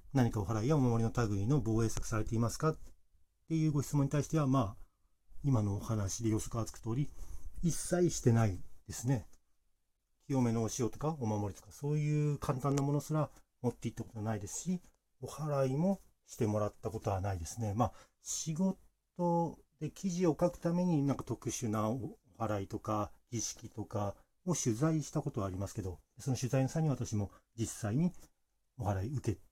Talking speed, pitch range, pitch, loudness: 360 characters per minute, 105-145 Hz, 115 Hz, -35 LUFS